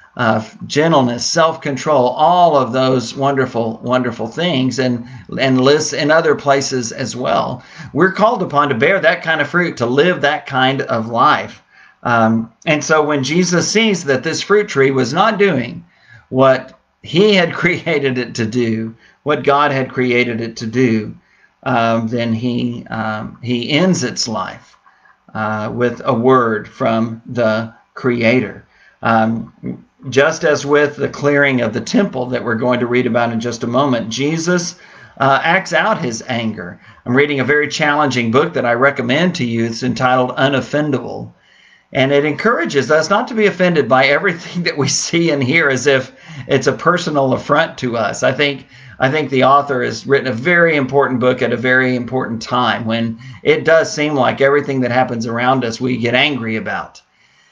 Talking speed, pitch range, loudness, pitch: 175 wpm, 120-150 Hz, -15 LUFS, 130 Hz